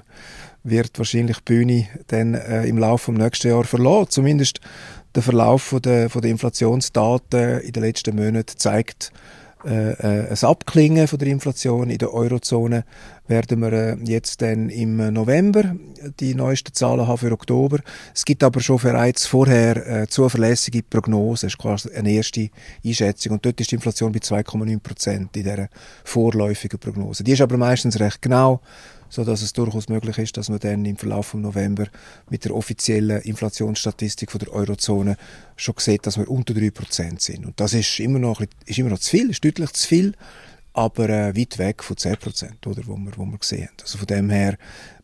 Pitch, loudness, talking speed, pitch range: 115 Hz, -20 LUFS, 185 wpm, 105-125 Hz